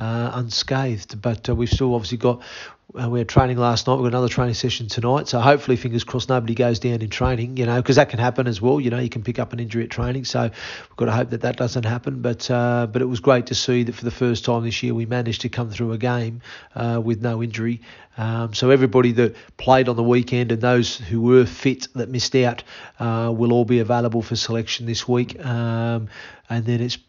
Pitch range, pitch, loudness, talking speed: 115-125 Hz, 120 Hz, -21 LUFS, 245 wpm